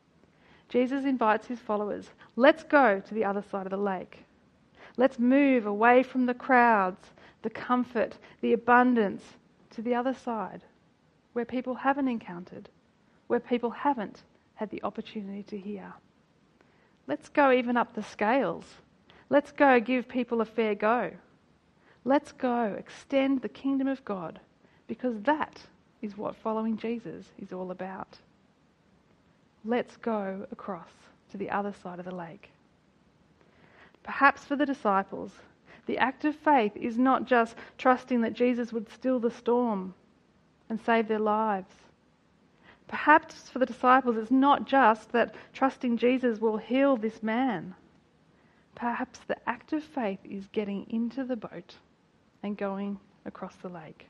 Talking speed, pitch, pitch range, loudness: 145 wpm, 235 Hz, 210-255 Hz, -28 LUFS